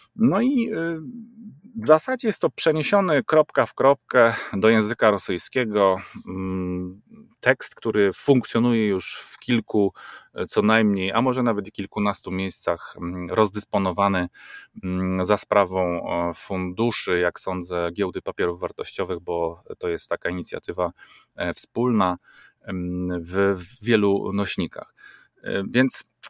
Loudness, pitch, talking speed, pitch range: -23 LUFS, 105 Hz, 105 wpm, 95-150 Hz